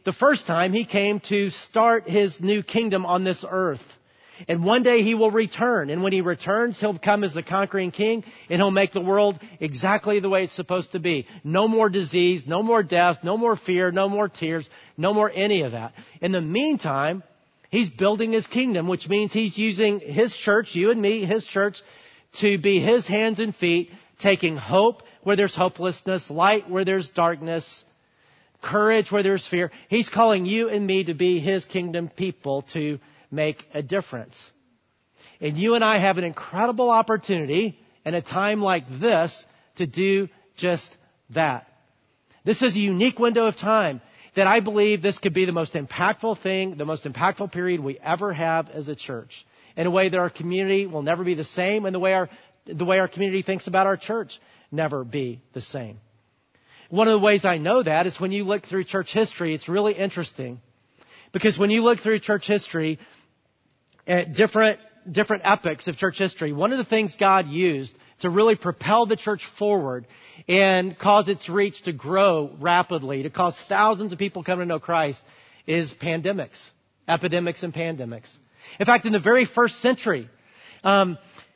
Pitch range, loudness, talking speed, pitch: 165-210 Hz, -22 LUFS, 185 wpm, 190 Hz